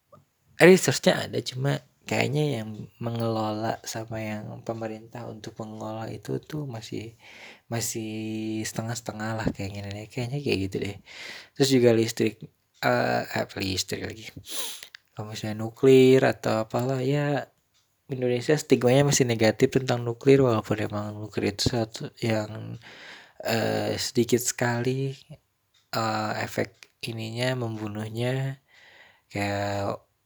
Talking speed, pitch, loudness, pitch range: 115 wpm, 115 Hz, -26 LUFS, 110-130 Hz